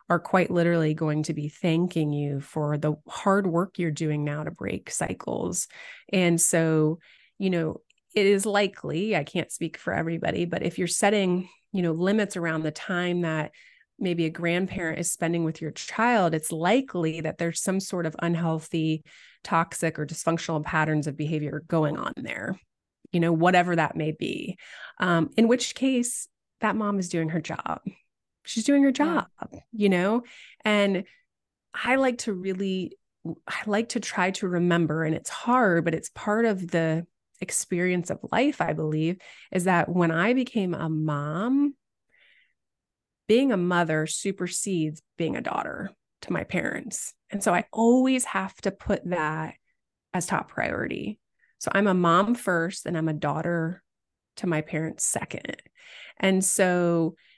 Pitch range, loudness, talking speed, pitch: 160-205 Hz, -26 LUFS, 160 wpm, 175 Hz